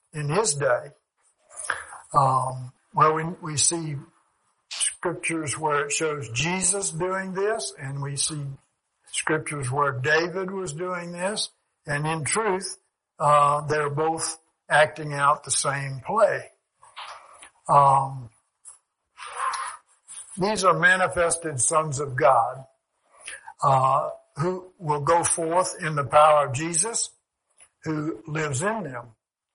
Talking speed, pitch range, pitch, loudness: 110 wpm, 140-175 Hz, 155 Hz, -24 LUFS